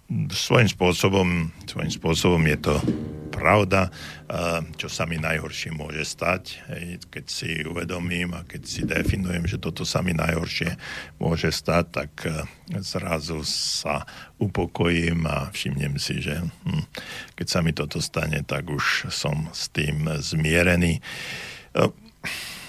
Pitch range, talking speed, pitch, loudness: 75-90 Hz, 120 wpm, 85 Hz, -25 LUFS